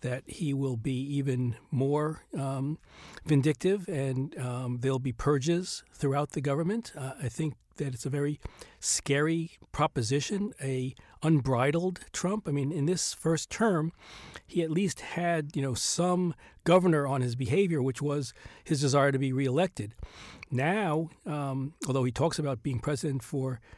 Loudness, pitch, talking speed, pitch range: -30 LUFS, 145 Hz, 150 wpm, 135-165 Hz